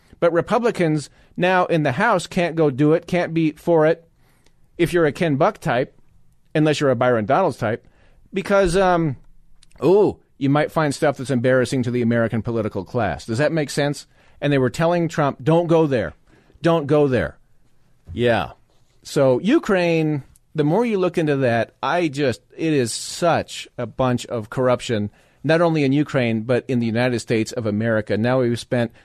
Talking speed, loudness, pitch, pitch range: 180 wpm, -20 LUFS, 145 Hz, 120-165 Hz